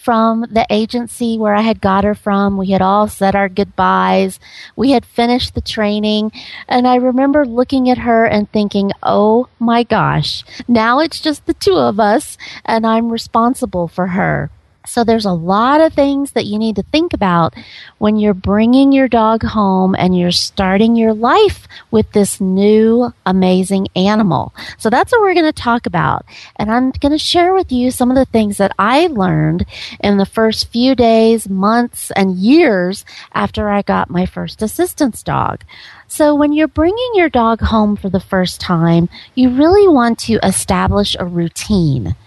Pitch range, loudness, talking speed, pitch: 195-250 Hz, -13 LUFS, 180 wpm, 220 Hz